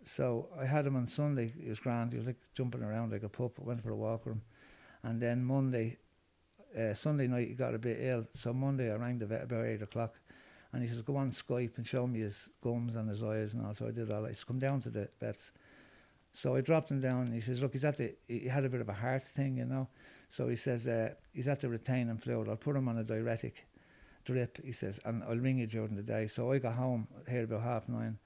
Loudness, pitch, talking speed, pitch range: -37 LUFS, 120 Hz, 270 wpm, 110-130 Hz